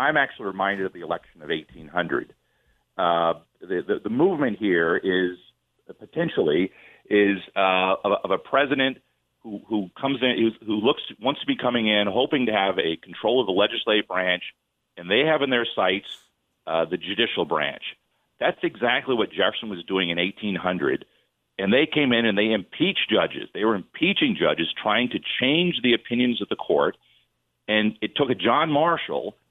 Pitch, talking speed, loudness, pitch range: 100 Hz, 175 wpm, -23 LUFS, 90-115 Hz